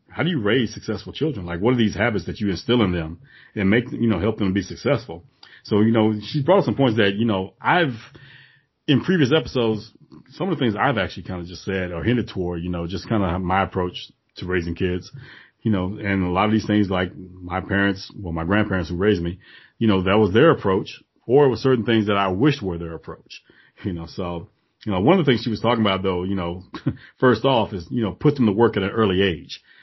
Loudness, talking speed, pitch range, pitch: -21 LUFS, 250 wpm, 90-115 Hz, 105 Hz